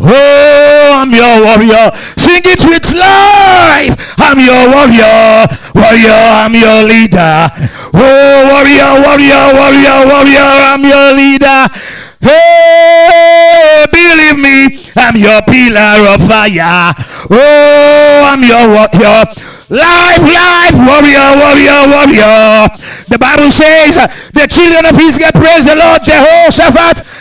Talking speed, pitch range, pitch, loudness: 115 wpm, 225-310 Hz, 280 Hz, -3 LUFS